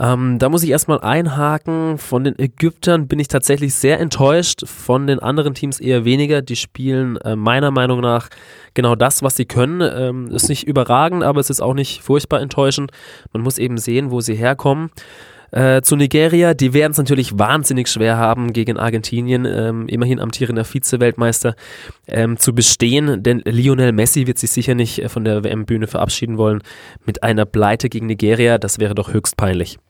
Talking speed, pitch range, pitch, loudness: 180 wpm, 115-140 Hz, 125 Hz, -16 LUFS